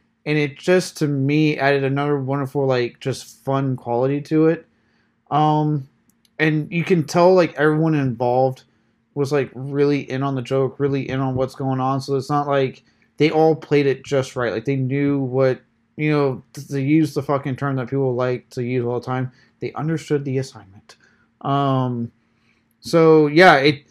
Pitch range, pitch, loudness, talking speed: 130-150 Hz, 140 Hz, -20 LUFS, 180 wpm